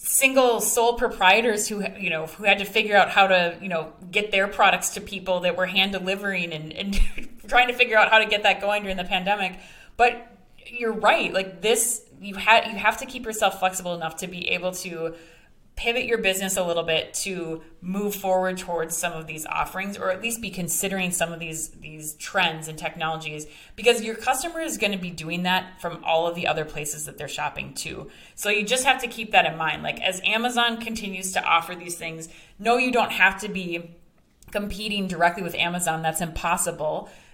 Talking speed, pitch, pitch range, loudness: 210 wpm, 190 Hz, 170-215 Hz, -23 LUFS